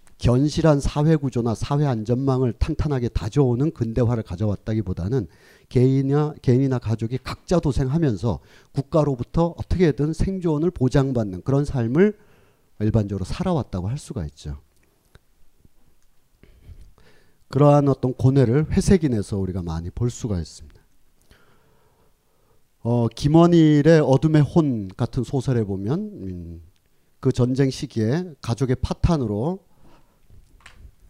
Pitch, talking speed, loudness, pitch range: 130 Hz, 275 characters per minute, -21 LUFS, 105-145 Hz